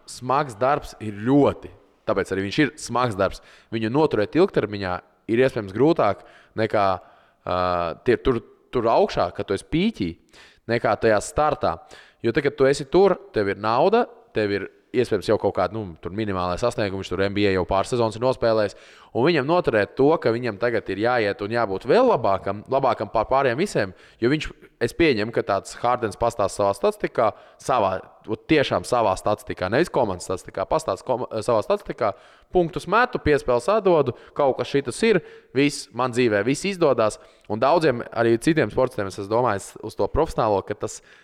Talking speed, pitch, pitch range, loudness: 165 wpm, 115 Hz, 100-140 Hz, -22 LUFS